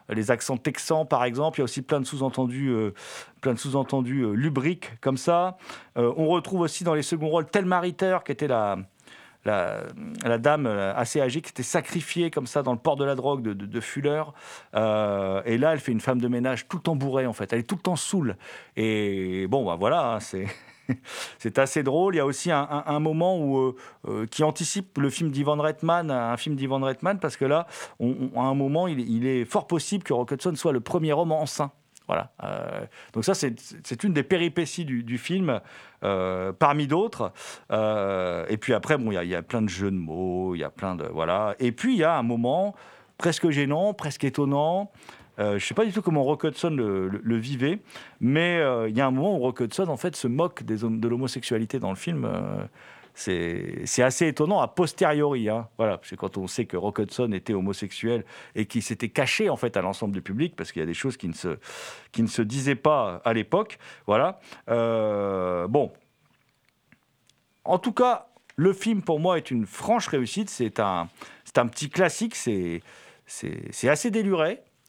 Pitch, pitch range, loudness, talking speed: 135 Hz, 115-160 Hz, -26 LUFS, 220 wpm